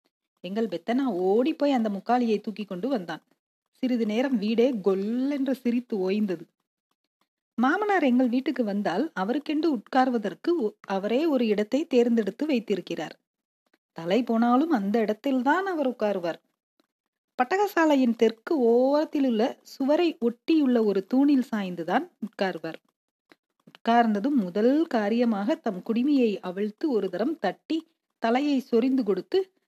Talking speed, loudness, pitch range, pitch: 110 wpm, -25 LUFS, 210-280 Hz, 240 Hz